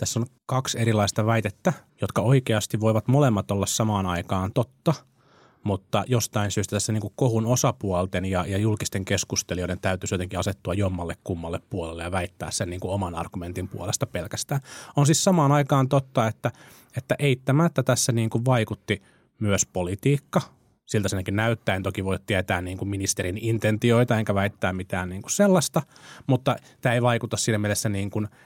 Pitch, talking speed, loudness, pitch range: 110 Hz, 160 wpm, -25 LUFS, 95-130 Hz